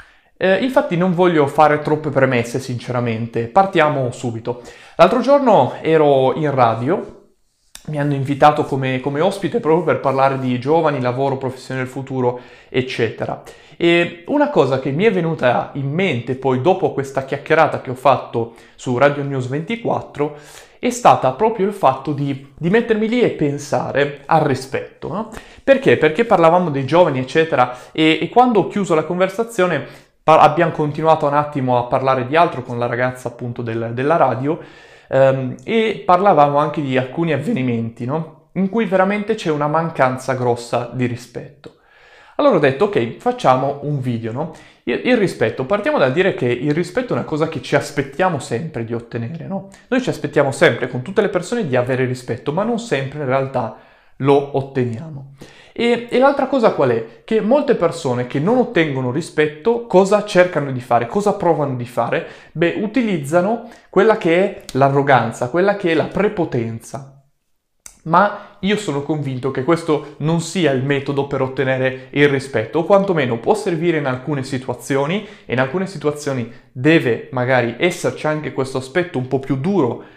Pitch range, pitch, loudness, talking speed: 130-180 Hz, 150 Hz, -17 LUFS, 165 wpm